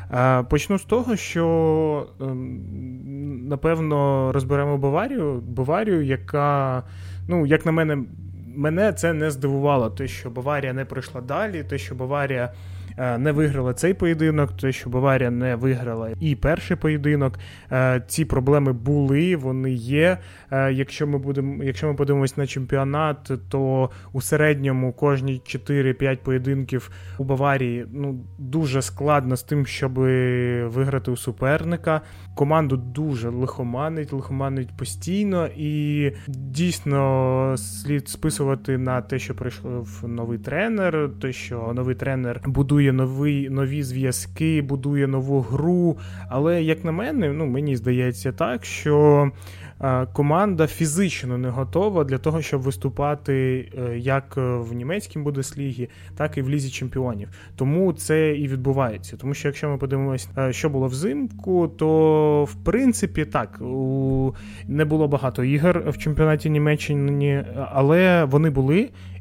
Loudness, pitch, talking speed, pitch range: -22 LUFS, 135 Hz, 125 wpm, 125-150 Hz